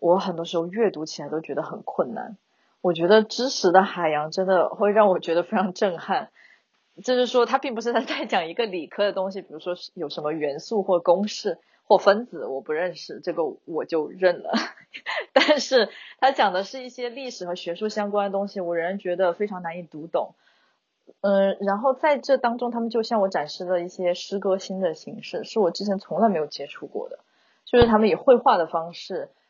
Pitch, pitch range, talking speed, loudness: 200 Hz, 175-240 Hz, 300 characters per minute, -24 LUFS